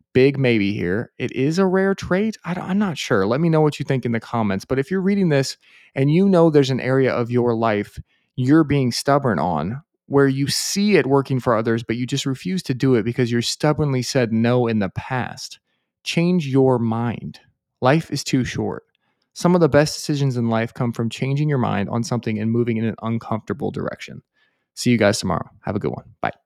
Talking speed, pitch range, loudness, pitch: 220 wpm, 120-150 Hz, -20 LUFS, 130 Hz